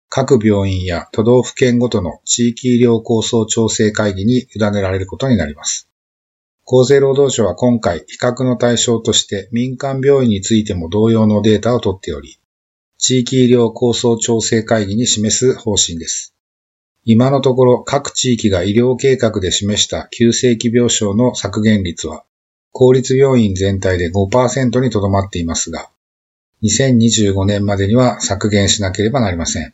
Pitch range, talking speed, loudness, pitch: 100-125 Hz, 300 characters per minute, -14 LUFS, 110 Hz